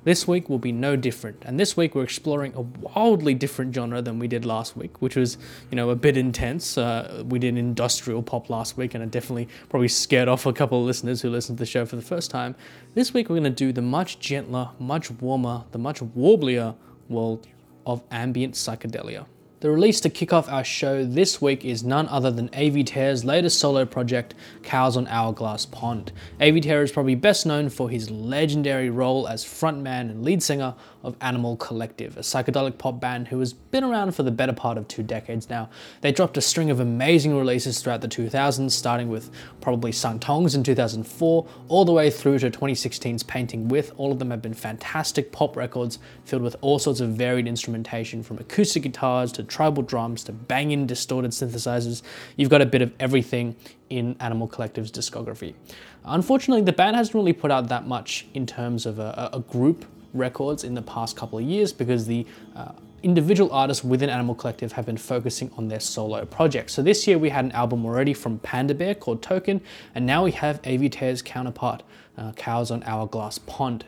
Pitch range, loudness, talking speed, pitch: 120-140 Hz, -24 LUFS, 205 wpm, 125 Hz